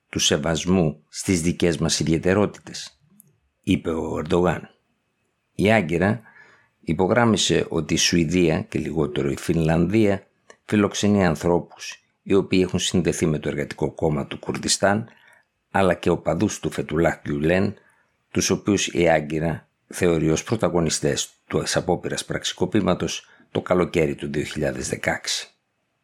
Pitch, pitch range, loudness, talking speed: 85 Hz, 80-95 Hz, -22 LUFS, 120 wpm